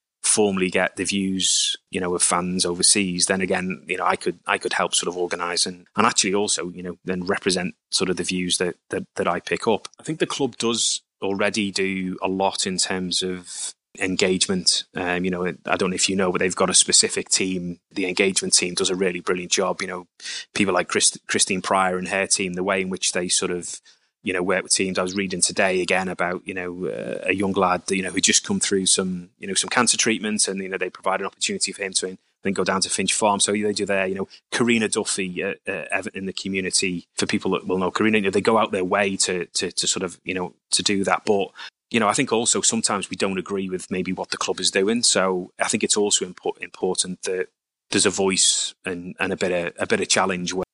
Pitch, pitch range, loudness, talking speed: 95 Hz, 90-100 Hz, -21 LUFS, 250 wpm